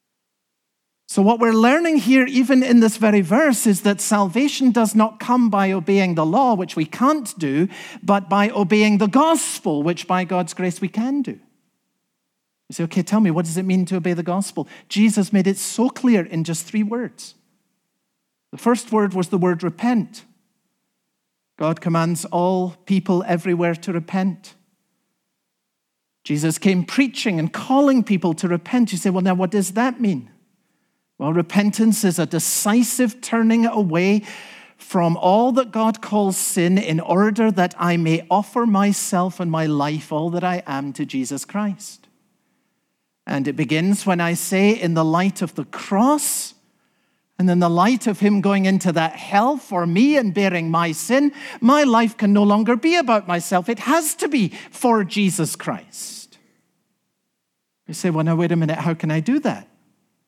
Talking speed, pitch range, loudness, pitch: 170 wpm, 175-230 Hz, -19 LUFS, 200 Hz